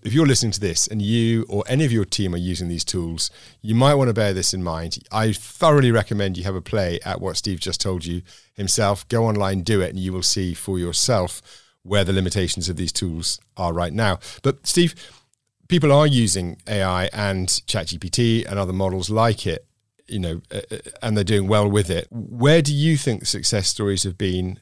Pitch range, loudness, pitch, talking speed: 90-115 Hz, -21 LUFS, 100 Hz, 210 wpm